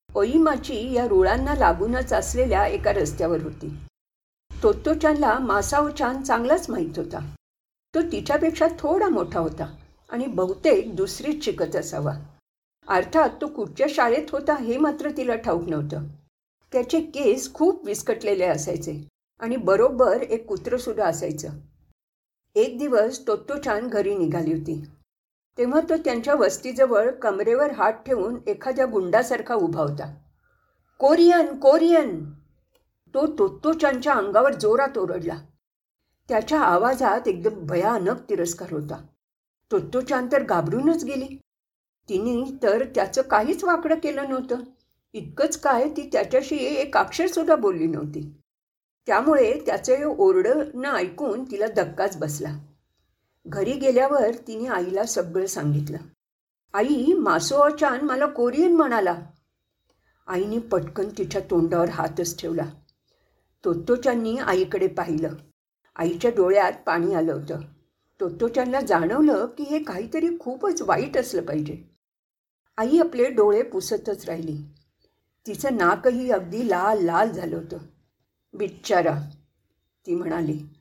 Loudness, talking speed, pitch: -23 LUFS, 115 wpm, 245 Hz